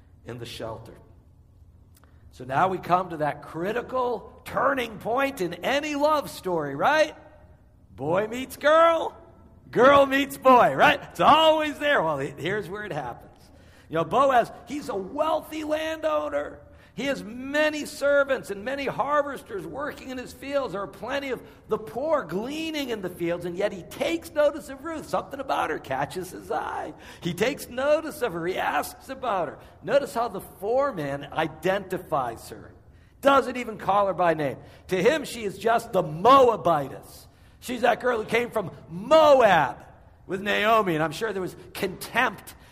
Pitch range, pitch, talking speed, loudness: 170-280 Hz, 225 Hz, 165 wpm, -24 LUFS